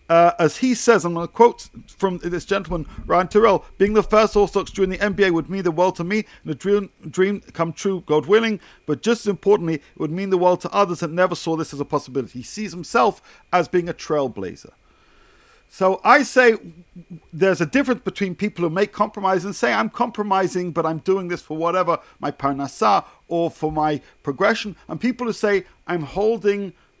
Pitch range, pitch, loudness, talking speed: 170-205 Hz, 185 Hz, -20 LUFS, 205 wpm